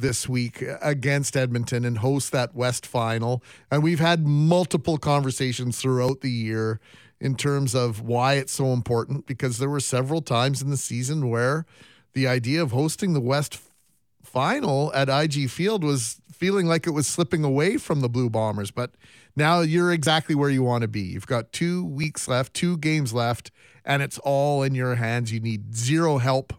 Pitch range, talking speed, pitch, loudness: 120-150 Hz, 185 wpm, 135 Hz, -24 LUFS